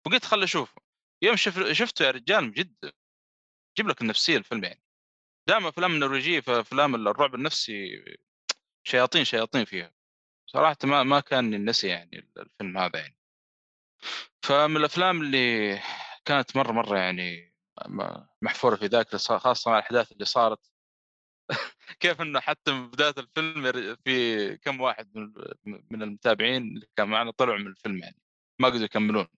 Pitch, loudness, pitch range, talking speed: 125 Hz, -26 LUFS, 105-150 Hz, 140 wpm